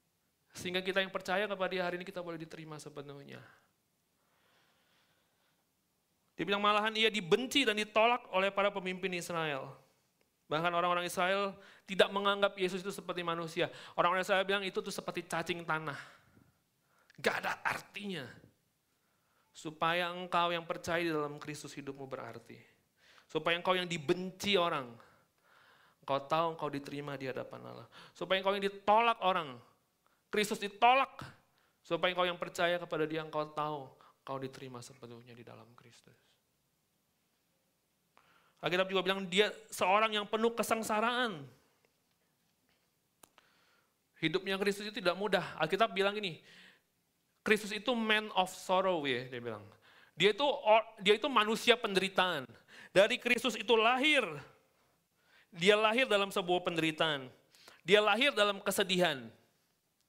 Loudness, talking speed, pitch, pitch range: -32 LUFS, 130 wpm, 185 Hz, 160-210 Hz